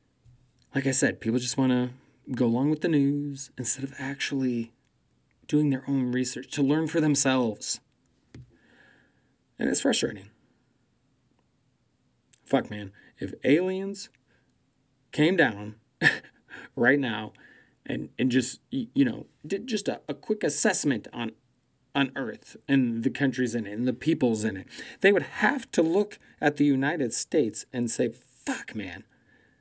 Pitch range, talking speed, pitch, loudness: 125-145 Hz, 140 wpm, 130 Hz, -26 LUFS